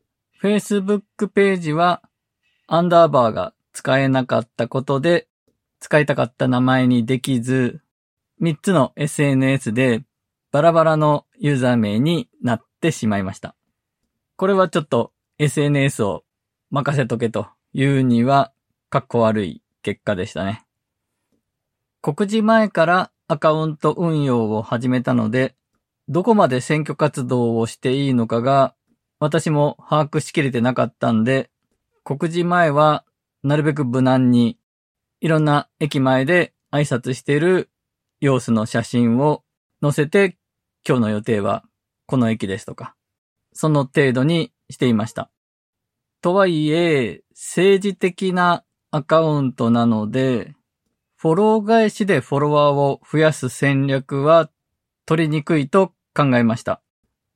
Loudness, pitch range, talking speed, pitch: -19 LUFS, 120-160 Hz, 260 characters per minute, 140 Hz